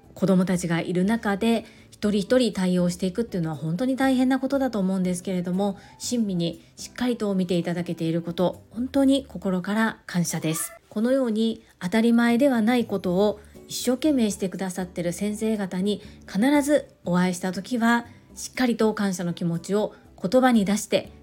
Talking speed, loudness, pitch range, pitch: 375 characters per minute, -24 LUFS, 180-235 Hz, 200 Hz